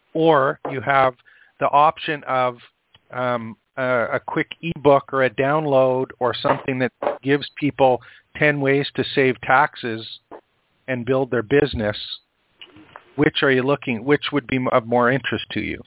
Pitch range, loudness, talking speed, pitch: 125-145 Hz, -20 LUFS, 150 wpm, 130 Hz